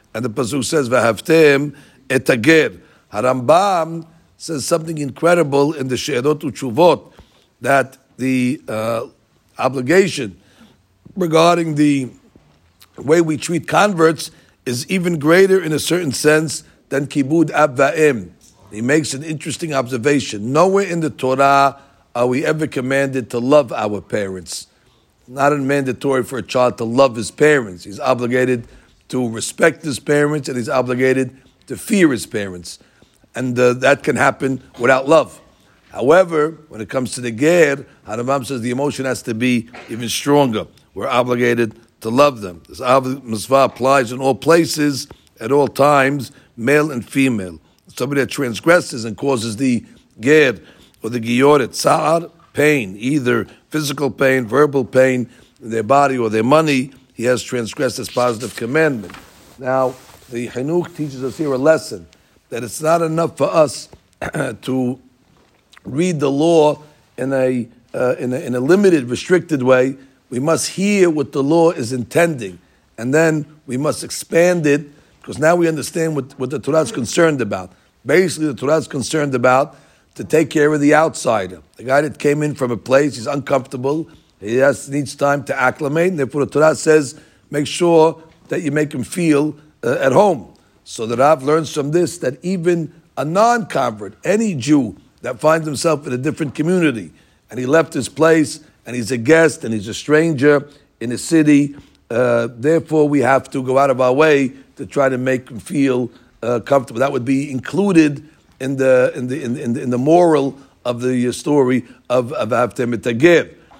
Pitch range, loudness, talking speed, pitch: 125-155 Hz, -17 LUFS, 165 wpm, 135 Hz